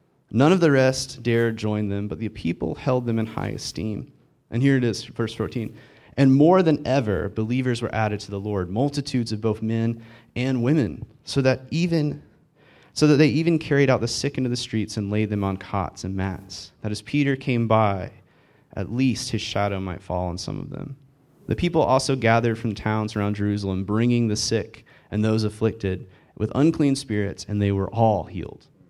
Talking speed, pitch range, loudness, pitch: 195 wpm, 105-135 Hz, -23 LUFS, 115 Hz